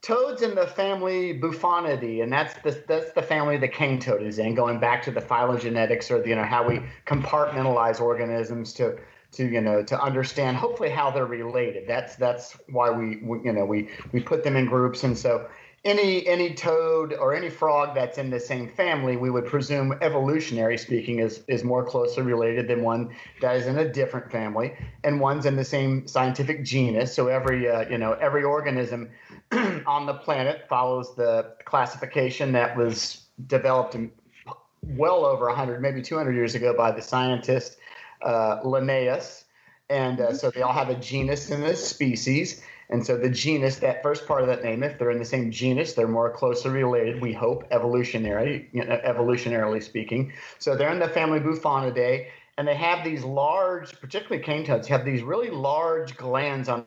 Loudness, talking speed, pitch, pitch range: -25 LUFS, 185 wpm, 130 Hz, 120-150 Hz